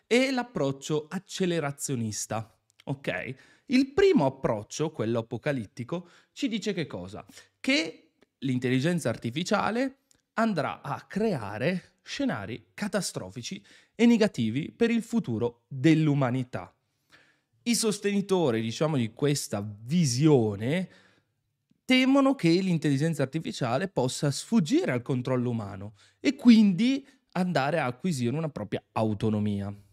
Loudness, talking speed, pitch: -27 LUFS, 100 wpm, 155 Hz